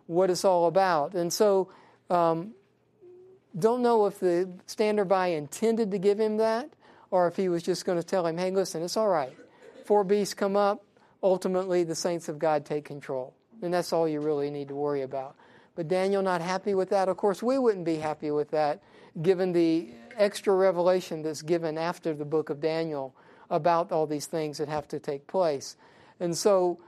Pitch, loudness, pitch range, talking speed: 180 Hz, -27 LUFS, 160-200 Hz, 195 wpm